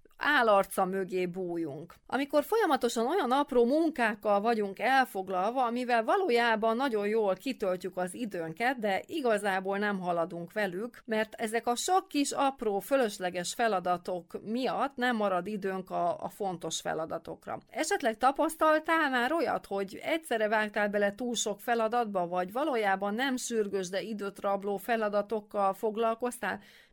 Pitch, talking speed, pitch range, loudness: 220 Hz, 130 wpm, 195-250 Hz, -30 LUFS